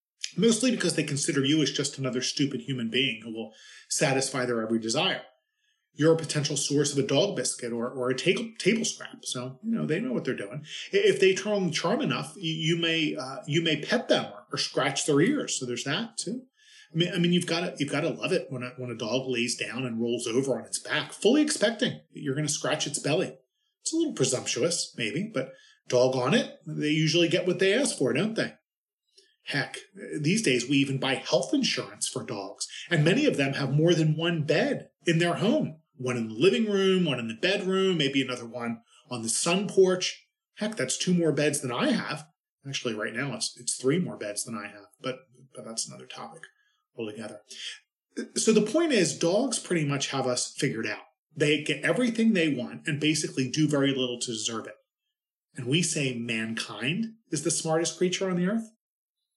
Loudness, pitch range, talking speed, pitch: -27 LUFS, 130-190 Hz, 210 wpm, 155 Hz